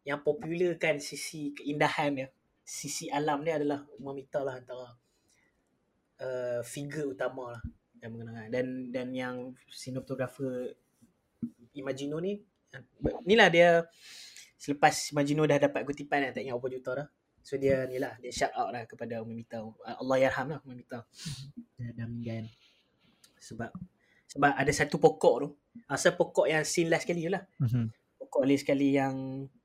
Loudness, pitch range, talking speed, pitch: -30 LUFS, 125-150 Hz, 150 wpm, 135 Hz